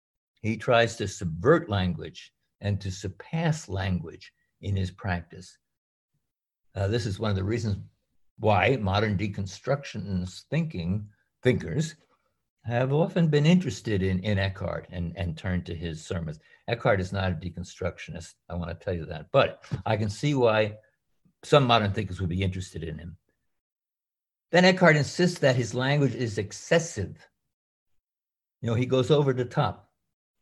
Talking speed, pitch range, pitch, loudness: 150 wpm, 95-130 Hz, 105 Hz, -27 LUFS